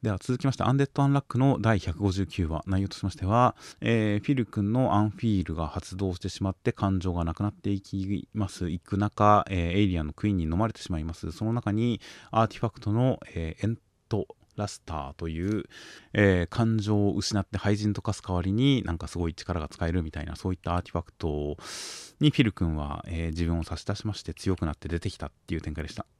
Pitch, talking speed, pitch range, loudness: 100 Hz, 440 characters per minute, 85-110 Hz, -28 LUFS